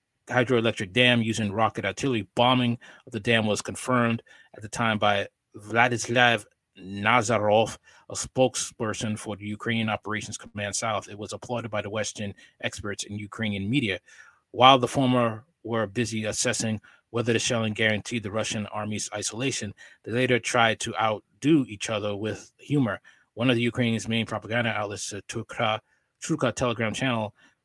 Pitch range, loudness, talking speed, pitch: 105-120 Hz, -26 LUFS, 150 wpm, 110 Hz